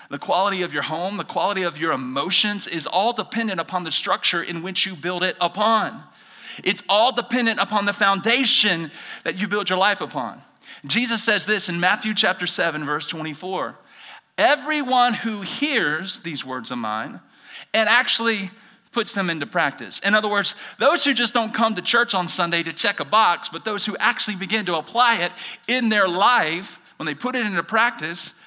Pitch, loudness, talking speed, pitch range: 205 Hz, -20 LUFS, 190 wpm, 175-230 Hz